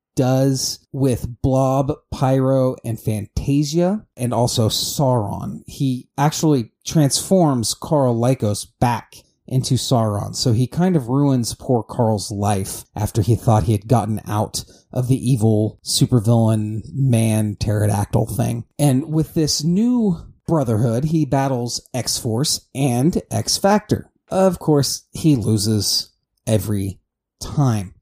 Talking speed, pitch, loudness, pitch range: 120 wpm, 125 Hz, -19 LUFS, 110-140 Hz